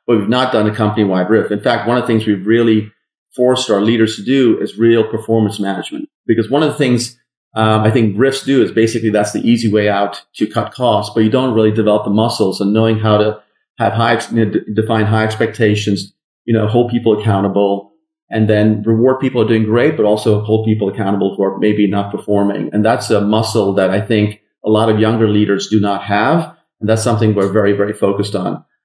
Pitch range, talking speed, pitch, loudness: 105-115 Hz, 225 wpm, 110 Hz, -14 LUFS